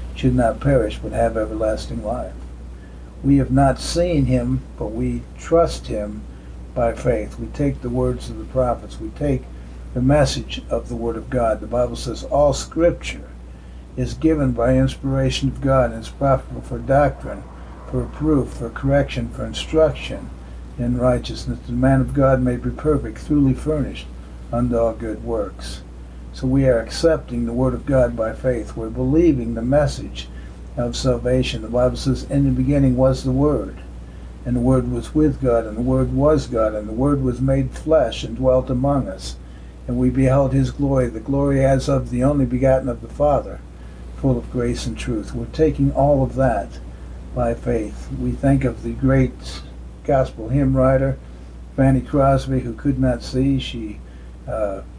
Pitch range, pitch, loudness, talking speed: 105-135 Hz, 125 Hz, -20 LUFS, 175 wpm